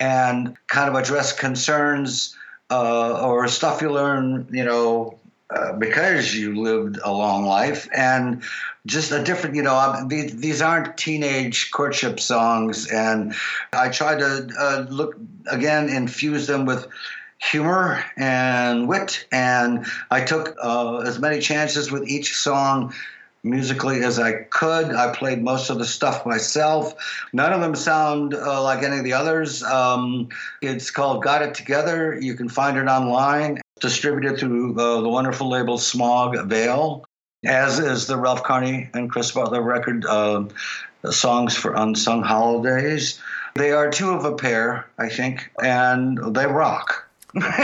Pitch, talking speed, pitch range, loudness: 130 Hz, 150 wpm, 120-145 Hz, -21 LUFS